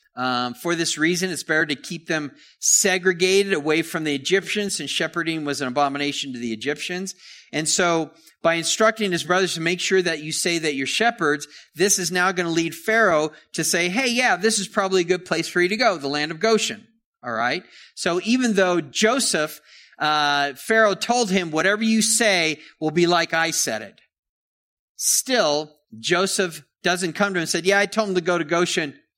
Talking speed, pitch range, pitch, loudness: 200 wpm, 155-195 Hz, 175 Hz, -21 LUFS